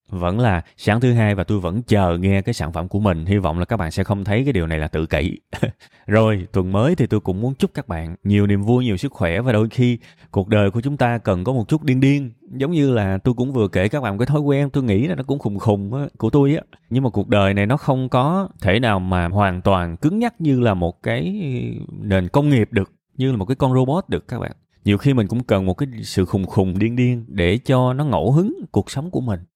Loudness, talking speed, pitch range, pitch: -19 LUFS, 275 wpm, 95-130 Hz, 110 Hz